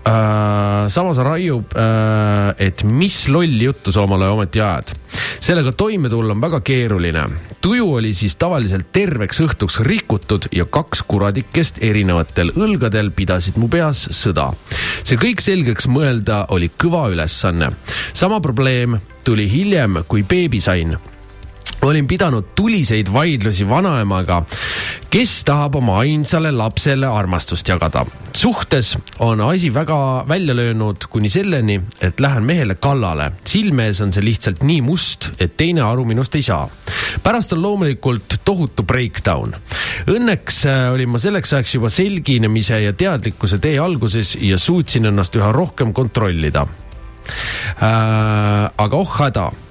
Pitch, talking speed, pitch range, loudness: 115 Hz, 135 wpm, 100-145 Hz, -16 LUFS